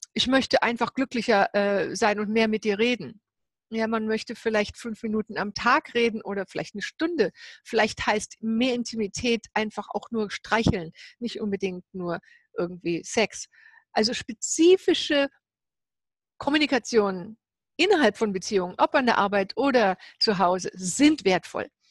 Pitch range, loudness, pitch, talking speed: 205-245 Hz, -25 LUFS, 220 Hz, 140 wpm